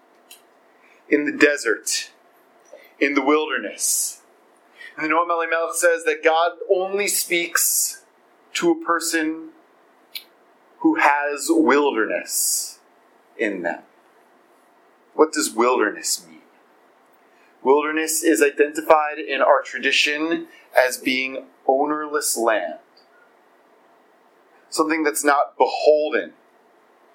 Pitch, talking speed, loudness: 170 Hz, 90 wpm, -20 LUFS